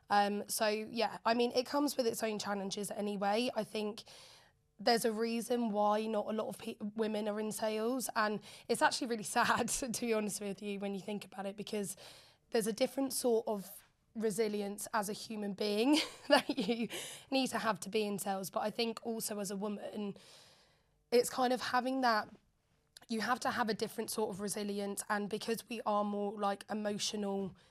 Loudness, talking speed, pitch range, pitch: -36 LUFS, 195 wpm, 205-235 Hz, 215 Hz